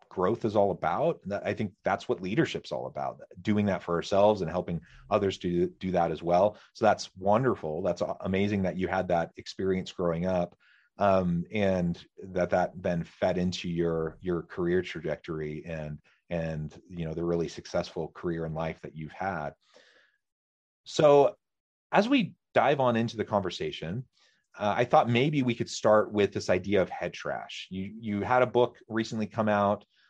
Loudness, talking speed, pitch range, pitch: -29 LUFS, 175 wpm, 85-110 Hz, 95 Hz